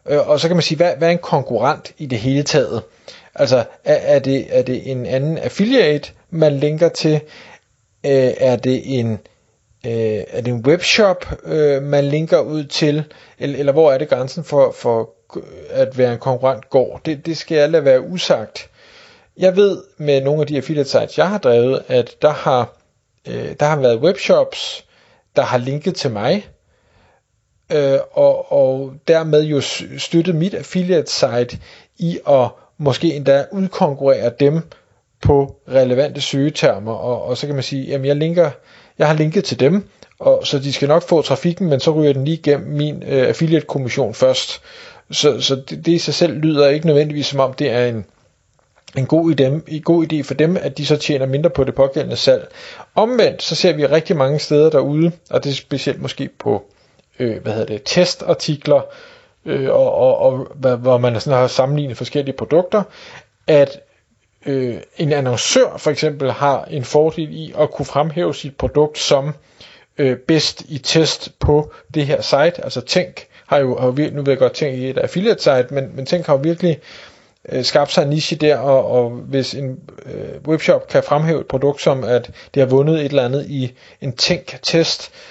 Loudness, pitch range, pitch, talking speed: -17 LUFS, 135-165 Hz, 145 Hz, 185 wpm